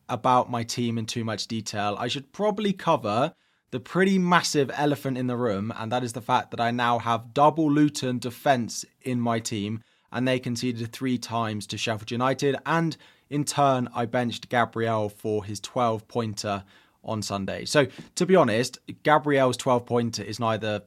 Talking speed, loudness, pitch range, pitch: 180 wpm, -26 LUFS, 110-135 Hz, 120 Hz